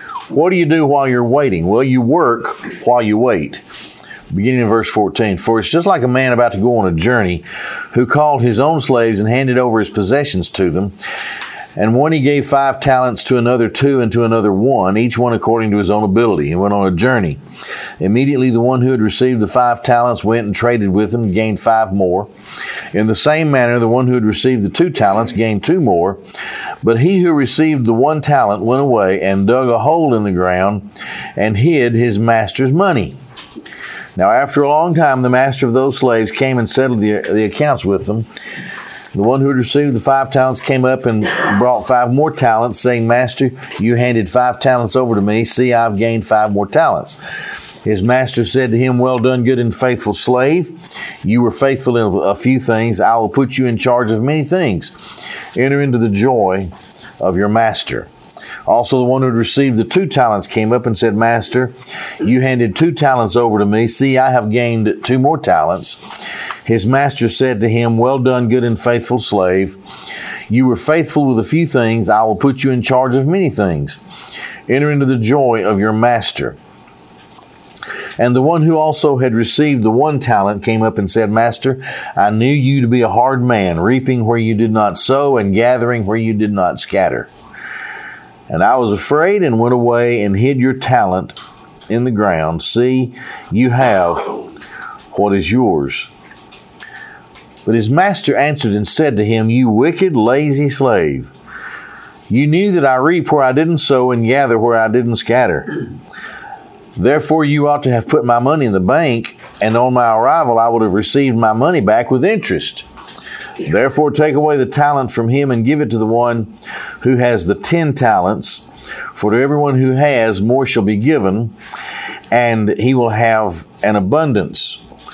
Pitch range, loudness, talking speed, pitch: 110-135 Hz, -13 LUFS, 195 wpm, 120 Hz